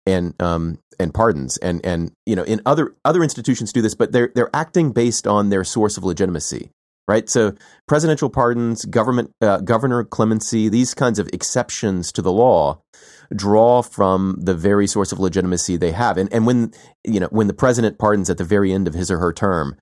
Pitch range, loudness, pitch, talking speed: 95-120 Hz, -18 LUFS, 105 Hz, 200 wpm